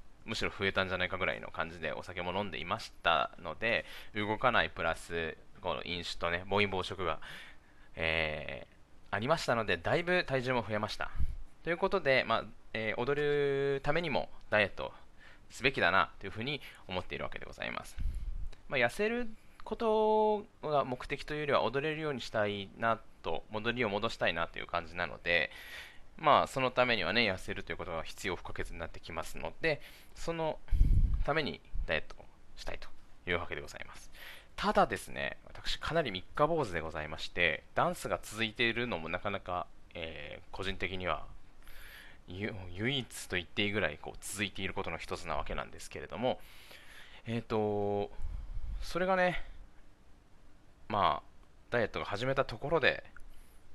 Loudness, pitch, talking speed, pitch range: -34 LUFS, 105 Hz, 350 characters per minute, 90-135 Hz